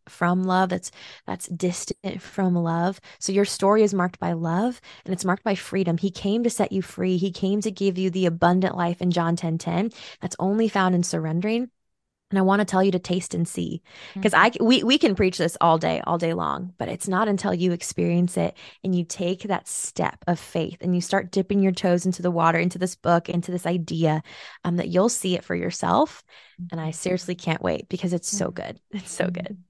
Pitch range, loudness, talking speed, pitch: 175-195 Hz, -24 LUFS, 225 wpm, 185 Hz